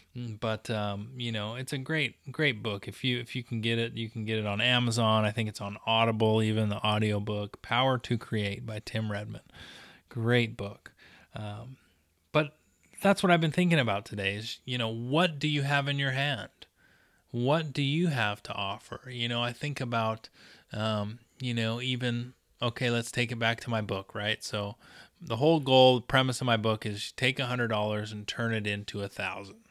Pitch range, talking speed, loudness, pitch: 105-130 Hz, 205 wpm, -29 LUFS, 115 Hz